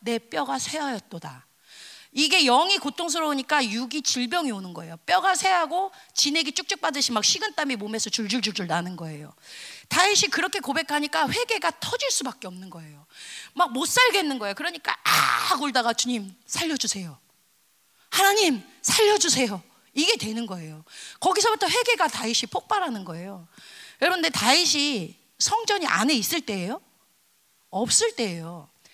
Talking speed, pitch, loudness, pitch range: 335 characters per minute, 275 Hz, -23 LUFS, 210-355 Hz